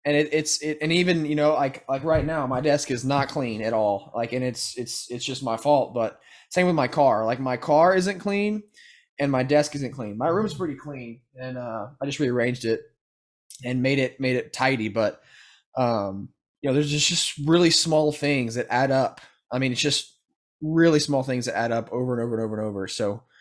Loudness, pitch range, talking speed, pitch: -24 LUFS, 120-150 Hz, 230 wpm, 130 Hz